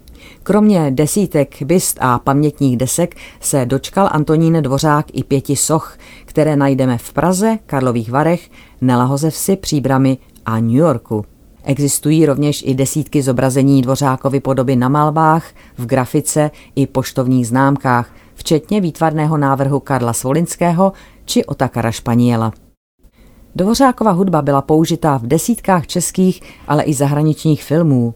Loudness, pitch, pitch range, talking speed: -15 LUFS, 140 Hz, 130-160 Hz, 120 wpm